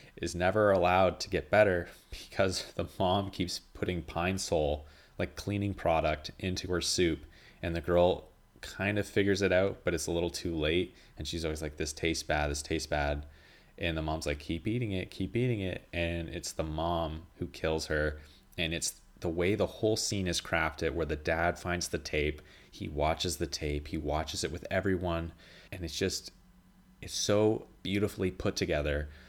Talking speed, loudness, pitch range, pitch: 190 wpm, -32 LUFS, 80-95 Hz, 85 Hz